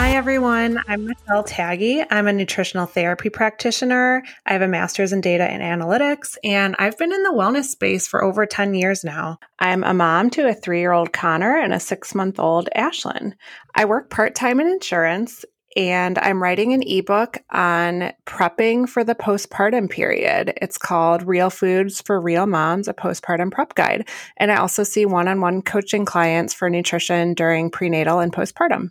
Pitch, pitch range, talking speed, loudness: 195 Hz, 175-230 Hz, 170 wpm, -19 LUFS